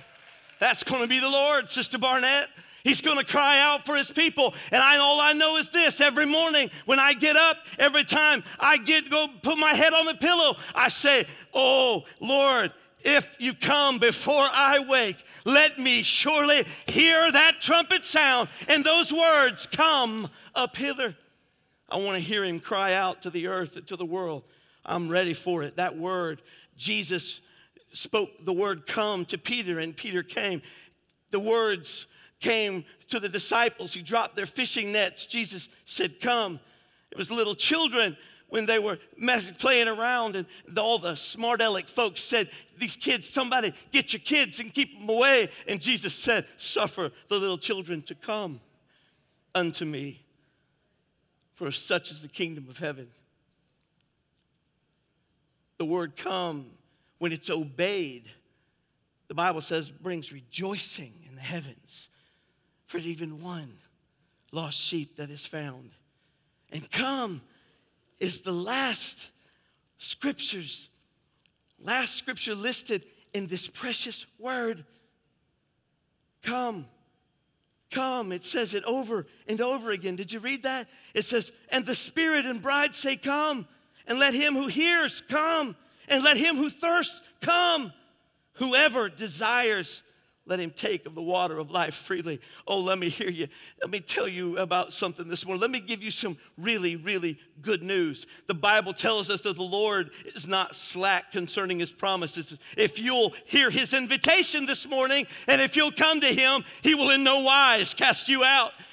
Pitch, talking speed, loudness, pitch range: 215 Hz, 160 wpm, -24 LUFS, 175-270 Hz